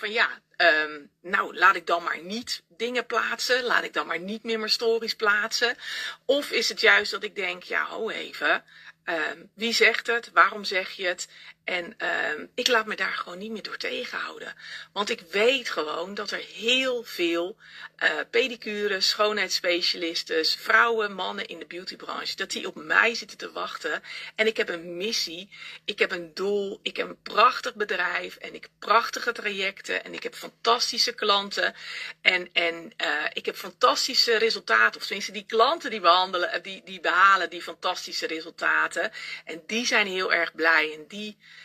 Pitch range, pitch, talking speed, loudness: 180-235 Hz, 210 Hz, 175 wpm, -25 LUFS